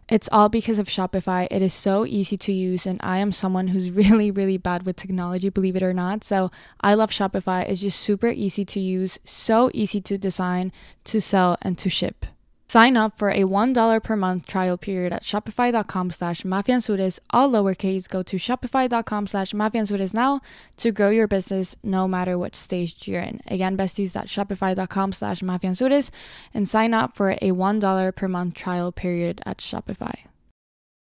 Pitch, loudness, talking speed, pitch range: 195 Hz, -22 LUFS, 175 wpm, 185-210 Hz